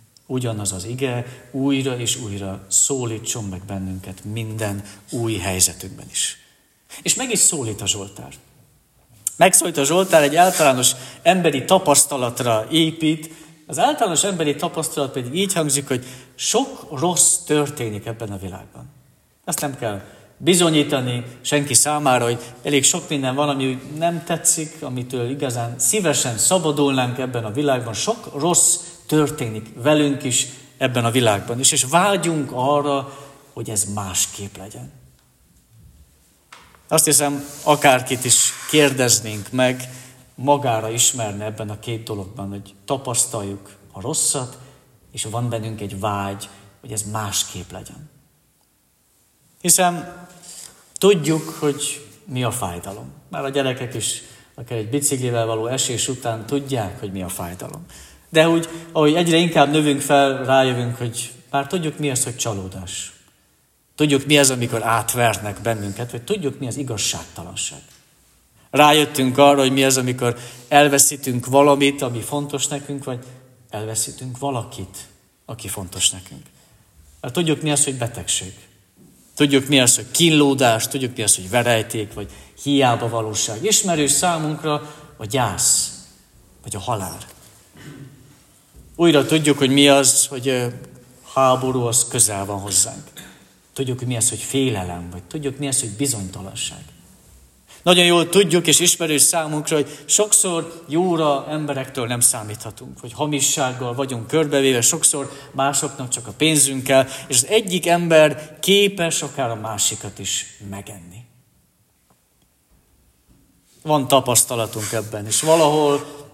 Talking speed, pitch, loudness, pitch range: 130 wpm, 130 Hz, -18 LUFS, 110-145 Hz